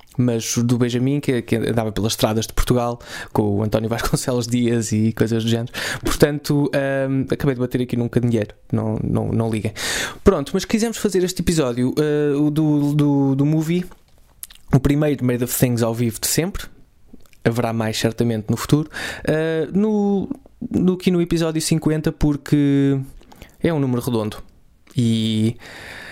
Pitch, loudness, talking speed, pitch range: 125 Hz, -20 LUFS, 160 wpm, 115-150 Hz